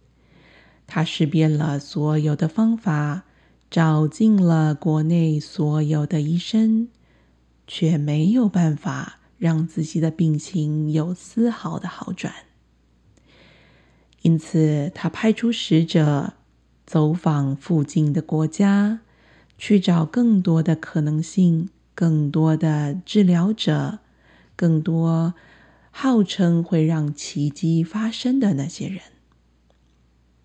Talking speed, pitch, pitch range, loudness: 155 characters per minute, 160 Hz, 150-180 Hz, -21 LUFS